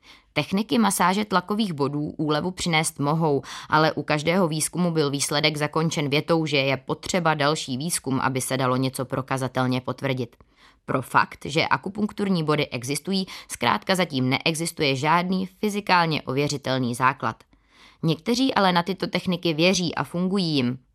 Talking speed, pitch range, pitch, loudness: 140 wpm, 135-180 Hz, 155 Hz, -23 LUFS